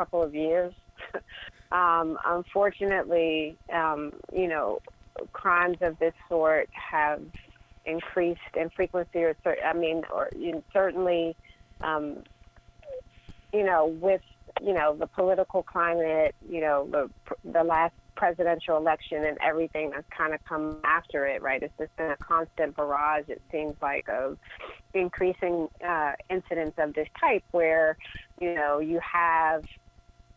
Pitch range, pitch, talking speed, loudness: 155-175 Hz, 165 Hz, 135 wpm, -28 LUFS